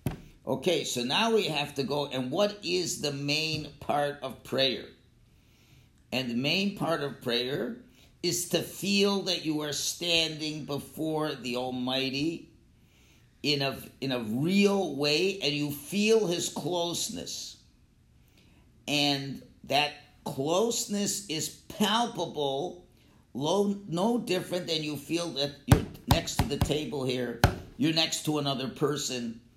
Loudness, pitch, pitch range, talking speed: -29 LUFS, 150 Hz, 135-175 Hz, 130 wpm